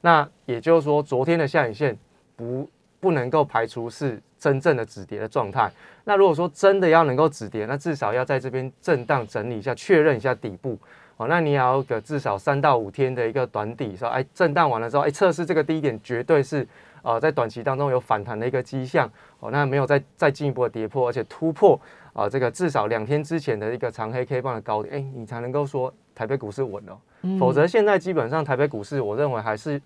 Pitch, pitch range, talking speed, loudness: 135 Hz, 120-155 Hz, 340 characters per minute, -23 LUFS